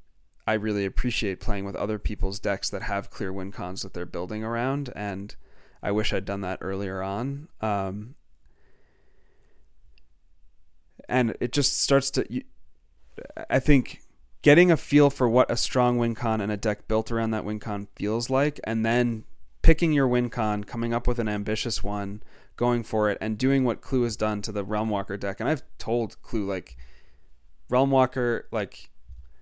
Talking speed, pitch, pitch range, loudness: 170 wpm, 105 Hz, 95-120 Hz, -26 LUFS